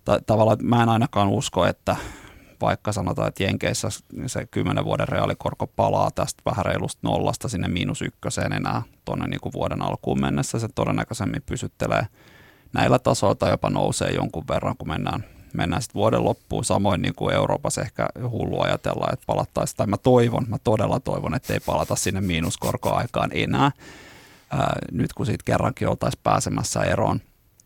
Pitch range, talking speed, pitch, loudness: 95-125 Hz, 160 wpm, 115 Hz, -24 LUFS